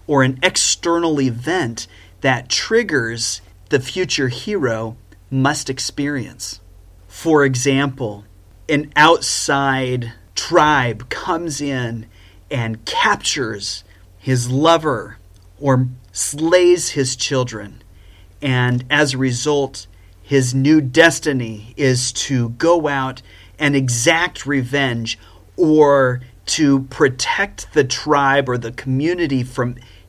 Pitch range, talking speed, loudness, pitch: 105-140 Hz, 100 wpm, -17 LUFS, 130 Hz